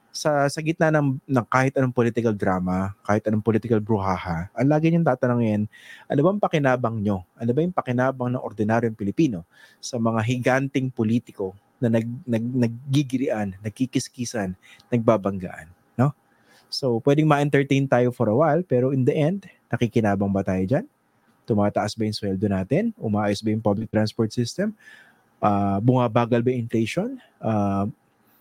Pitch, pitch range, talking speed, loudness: 120 Hz, 105-135 Hz, 150 wpm, -23 LUFS